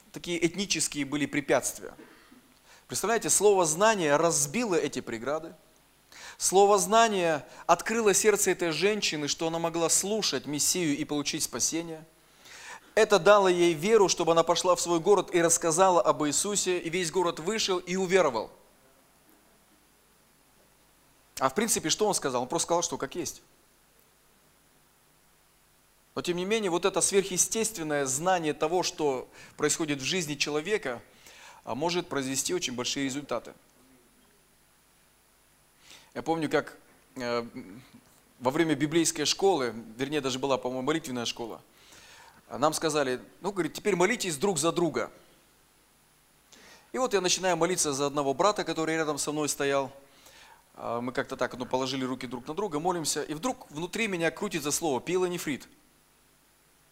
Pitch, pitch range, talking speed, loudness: 165 Hz, 145-190 Hz, 135 wpm, -27 LUFS